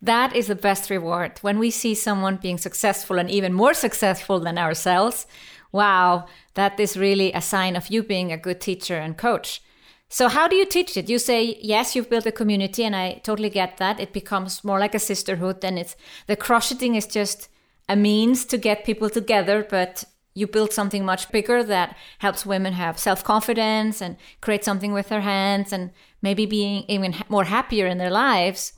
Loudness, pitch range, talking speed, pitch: -22 LUFS, 190-220 Hz, 195 wpm, 200 Hz